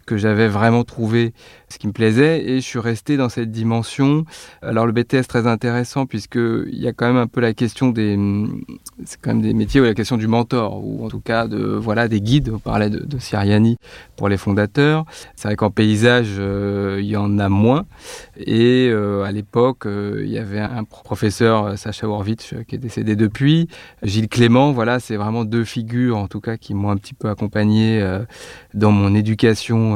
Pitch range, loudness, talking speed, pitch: 105-120 Hz, -18 LUFS, 205 wpm, 115 Hz